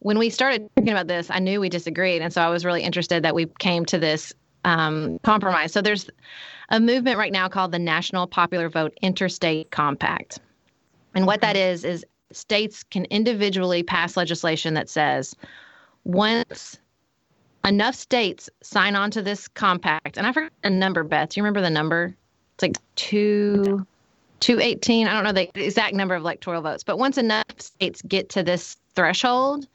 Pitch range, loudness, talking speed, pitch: 170-210 Hz, -22 LUFS, 180 wpm, 185 Hz